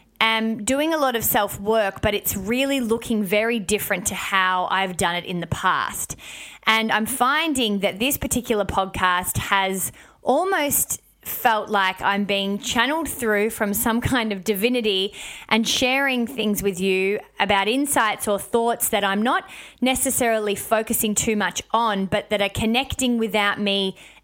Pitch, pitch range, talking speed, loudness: 215 Hz, 200-240 Hz, 160 wpm, -21 LUFS